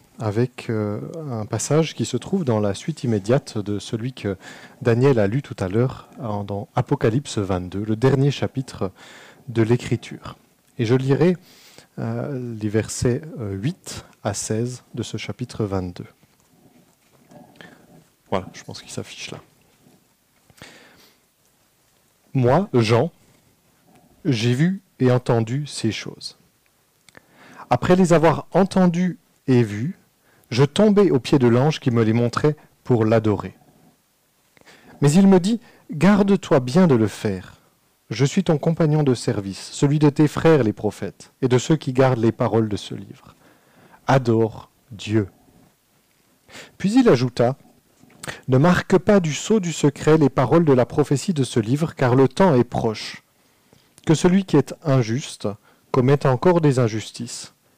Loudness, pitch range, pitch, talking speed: -20 LUFS, 115-155 Hz, 130 Hz, 140 wpm